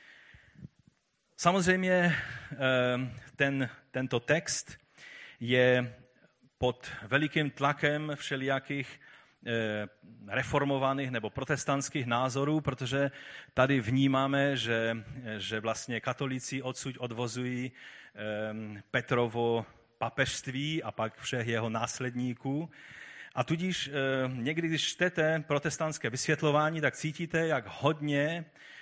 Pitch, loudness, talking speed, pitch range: 135 Hz, -31 LUFS, 85 wpm, 120-145 Hz